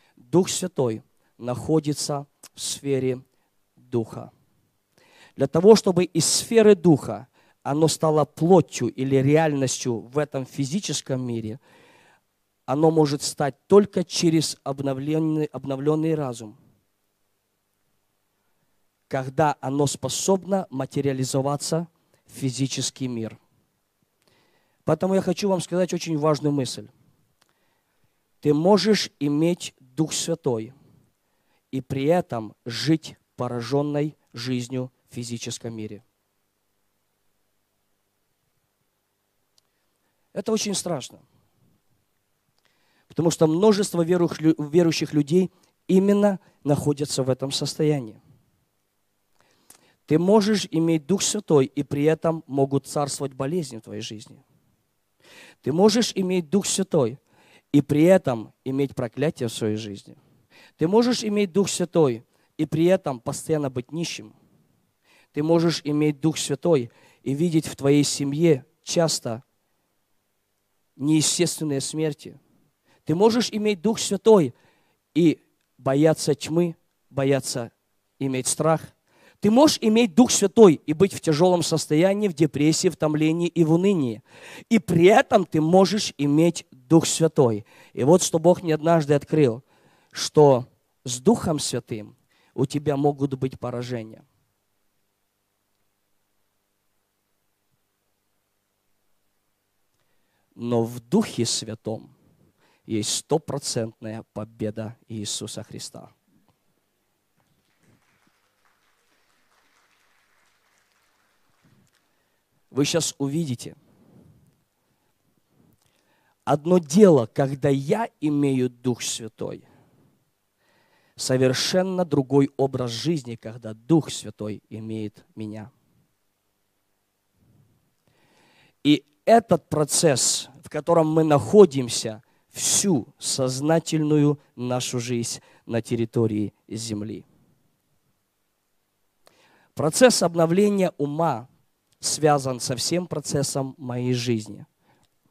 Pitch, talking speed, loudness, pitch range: 140 Hz, 95 wpm, -22 LUFS, 115-165 Hz